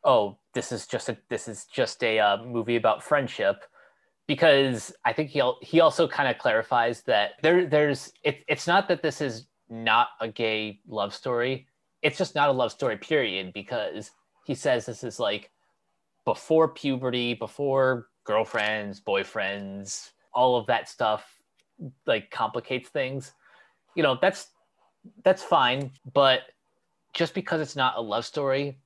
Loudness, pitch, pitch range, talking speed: -26 LUFS, 130 Hz, 115-150 Hz, 155 wpm